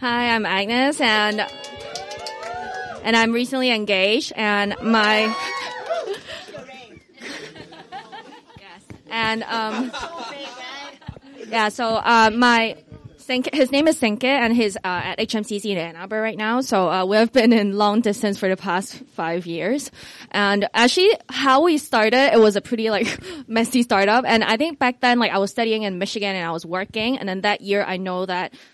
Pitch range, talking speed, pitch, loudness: 200-245 Hz, 160 wpm, 220 Hz, -20 LUFS